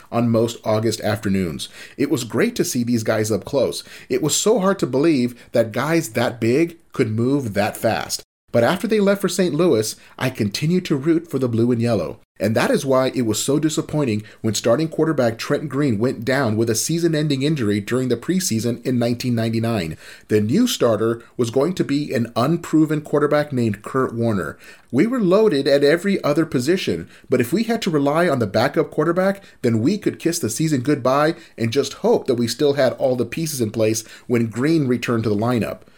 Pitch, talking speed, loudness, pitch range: 130 Hz, 205 wpm, -20 LUFS, 115-160 Hz